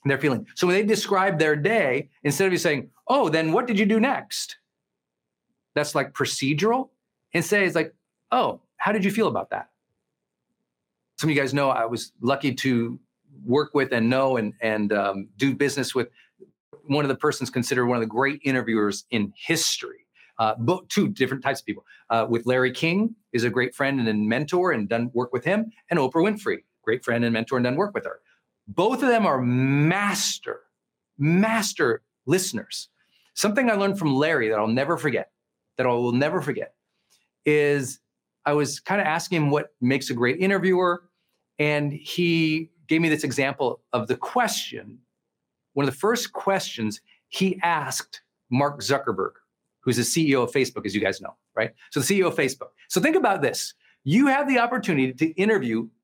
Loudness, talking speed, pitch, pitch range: -24 LUFS, 185 wpm, 150 Hz, 130-195 Hz